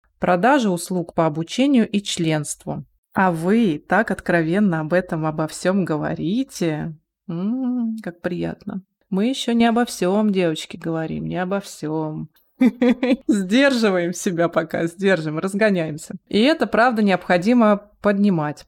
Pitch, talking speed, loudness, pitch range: 190 Hz, 120 wpm, -20 LUFS, 165-220 Hz